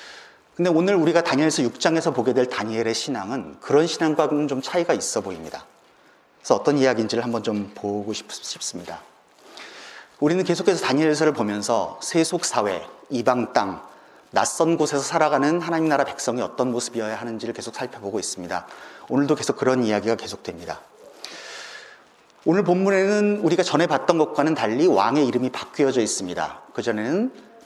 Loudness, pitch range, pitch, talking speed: -22 LUFS, 120-165 Hz, 145 Hz, 370 characters per minute